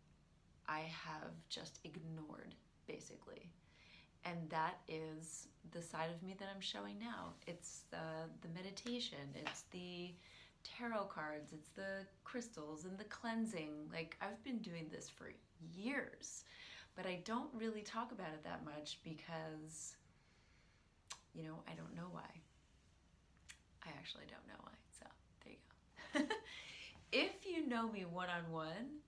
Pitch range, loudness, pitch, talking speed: 155-215 Hz, -48 LUFS, 170 Hz, 140 wpm